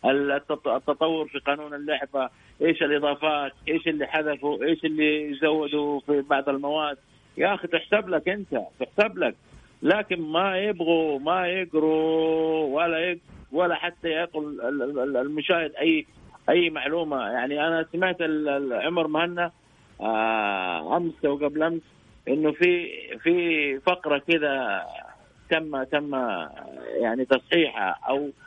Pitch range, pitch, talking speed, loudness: 145-170 Hz, 155 Hz, 115 wpm, -25 LUFS